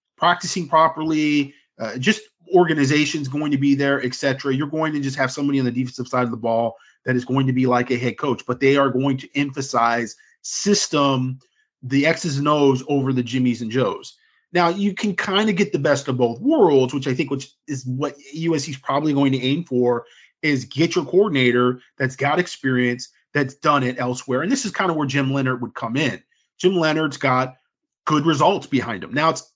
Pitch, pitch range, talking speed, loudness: 140 Hz, 130-160 Hz, 210 wpm, -20 LUFS